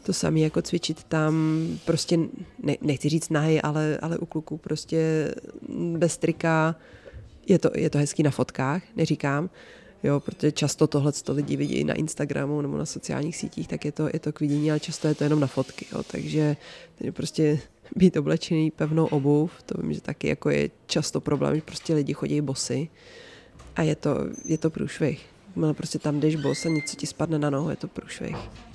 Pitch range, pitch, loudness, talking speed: 150-160 Hz, 155 Hz, -26 LUFS, 195 wpm